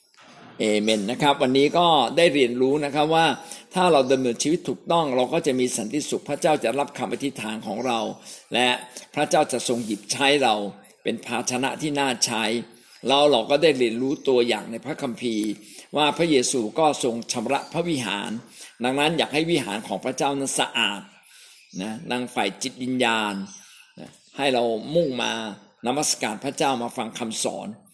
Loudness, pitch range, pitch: -23 LUFS, 120-145 Hz, 130 Hz